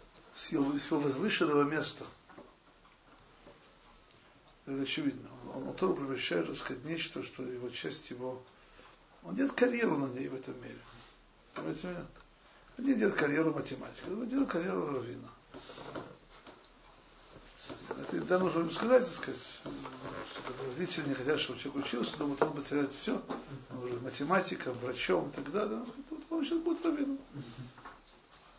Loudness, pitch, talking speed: -35 LUFS, 155 Hz, 140 wpm